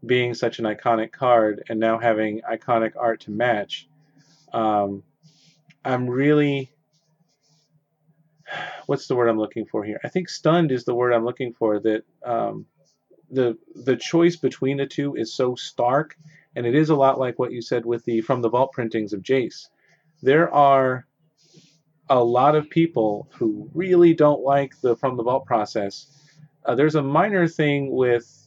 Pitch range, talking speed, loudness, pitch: 120-155 Hz, 170 wpm, -22 LUFS, 135 Hz